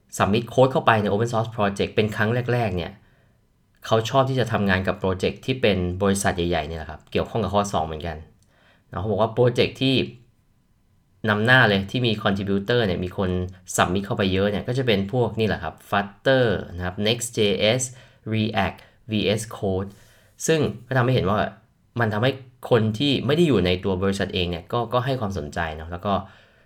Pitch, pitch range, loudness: 105 Hz, 95-120 Hz, -23 LUFS